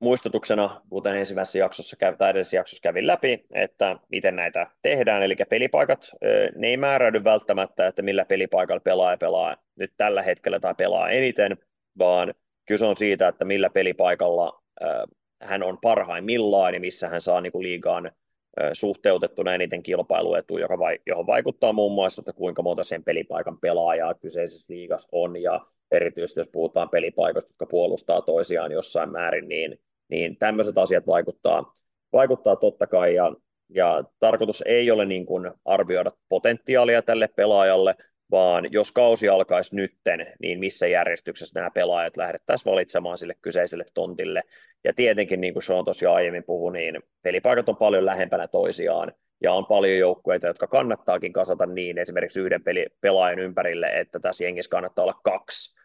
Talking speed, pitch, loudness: 145 wpm, 130 Hz, -23 LUFS